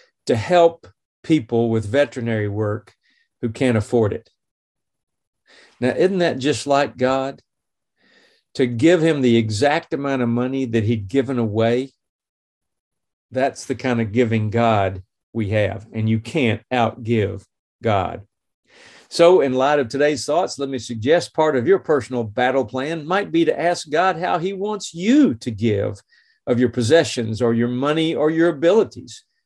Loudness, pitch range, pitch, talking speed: -19 LUFS, 115-155 Hz, 125 Hz, 155 wpm